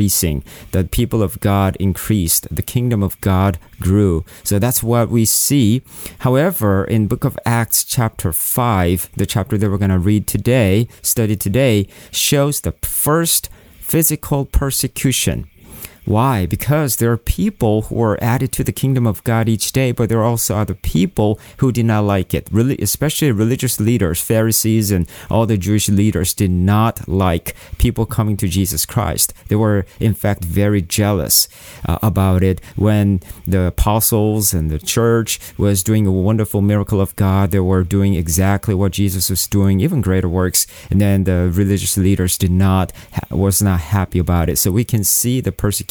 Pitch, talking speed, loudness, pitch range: 100 Hz, 175 wpm, -16 LUFS, 95-115 Hz